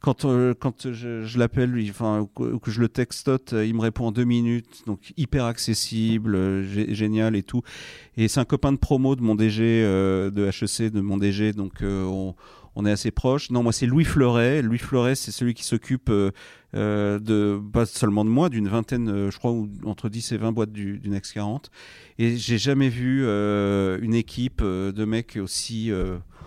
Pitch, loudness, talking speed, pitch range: 110 Hz, -24 LUFS, 200 wpm, 105-120 Hz